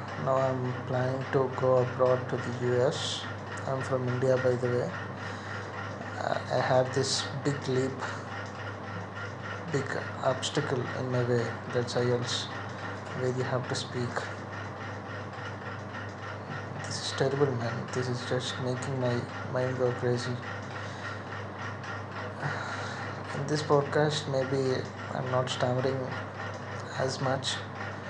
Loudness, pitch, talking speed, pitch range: -31 LUFS, 120 Hz, 115 wpm, 105-130 Hz